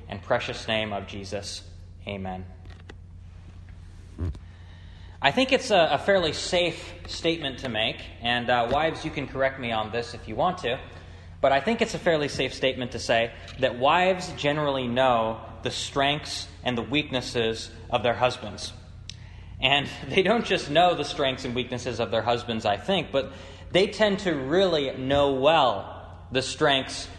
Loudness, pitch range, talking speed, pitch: -25 LUFS, 90-140 Hz, 165 wpm, 120 Hz